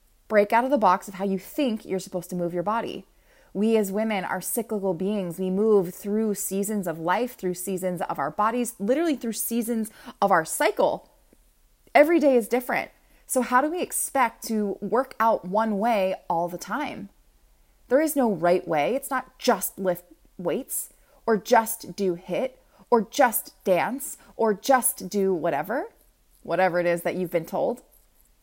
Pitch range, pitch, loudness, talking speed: 185-245 Hz, 210 Hz, -25 LUFS, 175 wpm